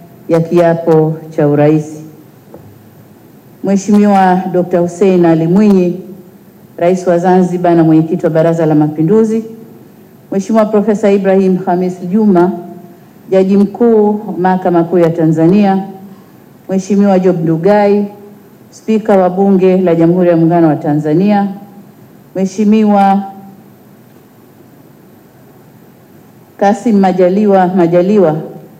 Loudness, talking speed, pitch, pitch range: -10 LUFS, 95 wpm, 185 Hz, 170-200 Hz